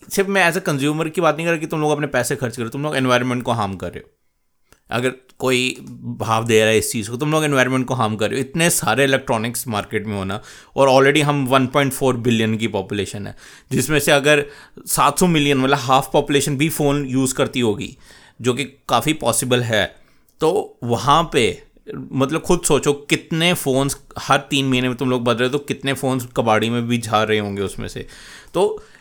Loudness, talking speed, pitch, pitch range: -18 LUFS, 215 wpm, 130 Hz, 120-145 Hz